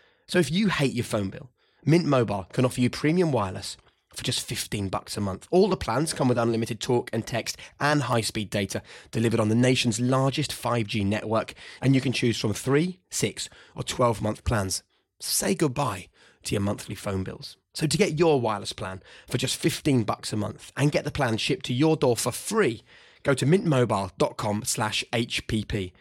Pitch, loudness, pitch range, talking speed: 120 Hz, -26 LUFS, 105-140 Hz, 190 wpm